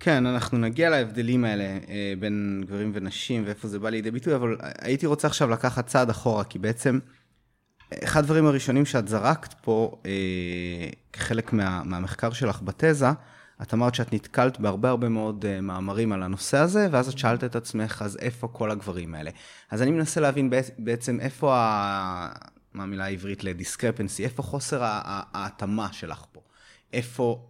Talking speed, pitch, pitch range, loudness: 160 wpm, 115 Hz, 100-130 Hz, -26 LUFS